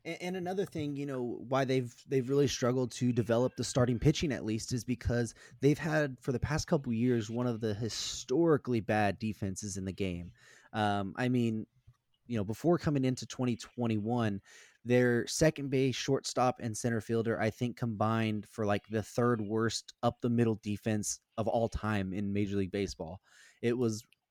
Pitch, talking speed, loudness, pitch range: 120 Hz, 180 wpm, -33 LUFS, 110-130 Hz